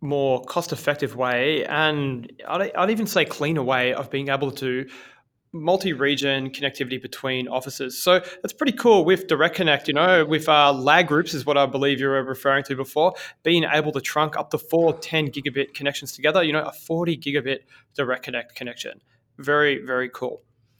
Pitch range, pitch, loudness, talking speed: 130-155 Hz, 140 Hz, -22 LUFS, 180 wpm